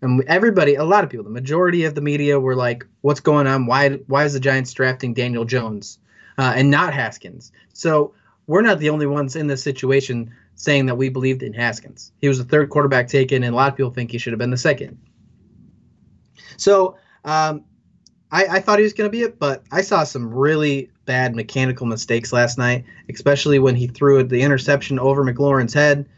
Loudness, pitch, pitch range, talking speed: -18 LUFS, 135 Hz, 125-145 Hz, 210 wpm